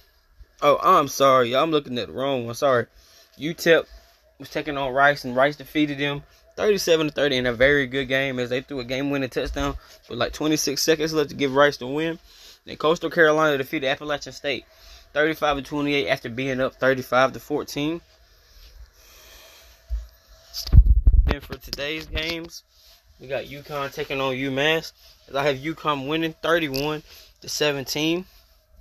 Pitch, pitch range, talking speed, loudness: 140 Hz, 130-155 Hz, 145 wpm, -23 LUFS